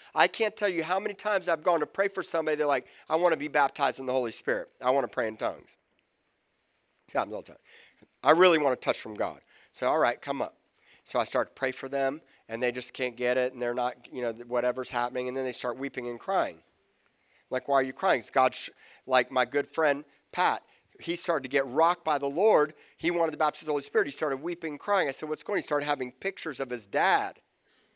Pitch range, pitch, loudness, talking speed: 130-165 Hz, 140 Hz, -29 LUFS, 255 wpm